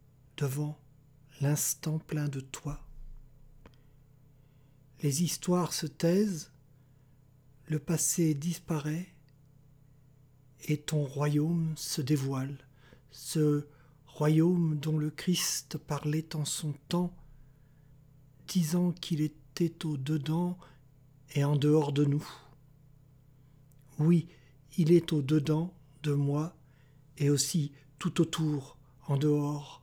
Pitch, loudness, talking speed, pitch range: 145 Hz, -31 LUFS, 95 wpm, 140-155 Hz